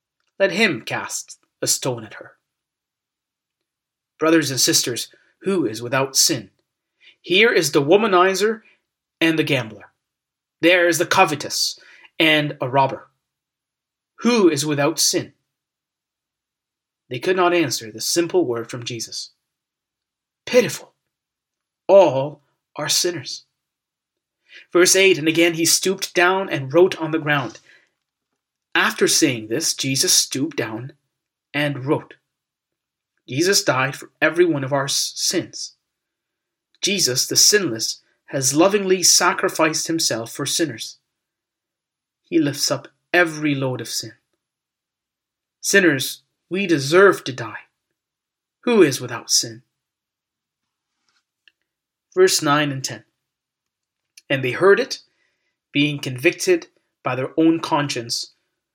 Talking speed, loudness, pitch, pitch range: 115 wpm, -18 LUFS, 160 Hz, 135-180 Hz